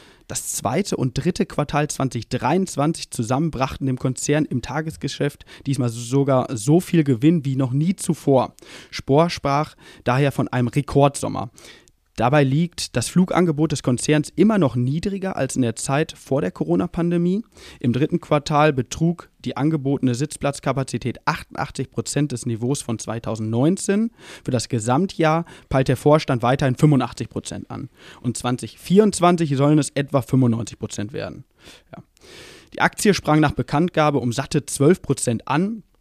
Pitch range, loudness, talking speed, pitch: 125-160 Hz, -21 LUFS, 140 wpm, 140 Hz